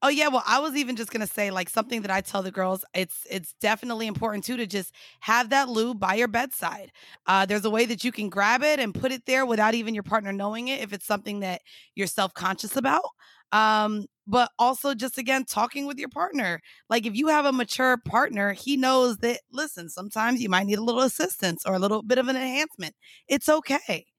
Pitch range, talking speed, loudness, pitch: 205-260 Hz, 230 wpm, -25 LUFS, 230 Hz